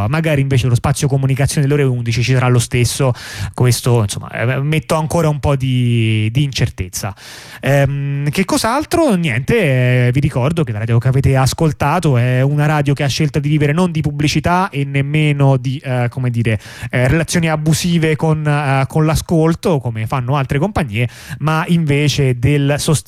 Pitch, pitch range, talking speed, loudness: 140 Hz, 125-155 Hz, 170 wpm, -15 LUFS